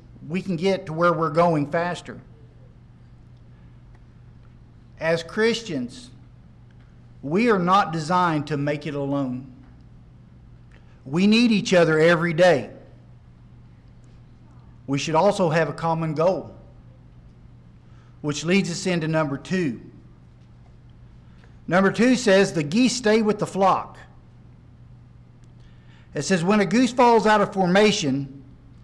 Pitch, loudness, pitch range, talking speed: 160 Hz, -21 LUFS, 120-190 Hz, 115 wpm